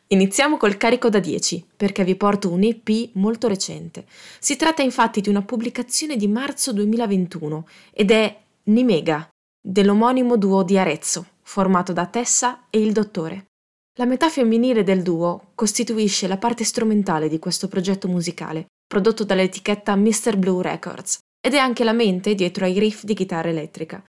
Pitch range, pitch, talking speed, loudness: 185-235 Hz, 205 Hz, 155 wpm, -20 LUFS